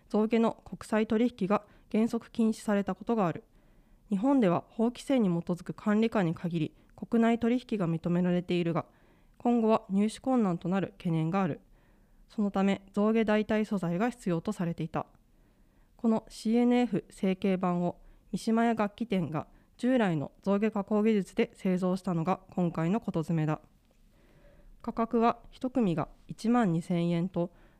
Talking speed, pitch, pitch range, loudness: 285 characters per minute, 200 Hz, 175-225 Hz, -30 LUFS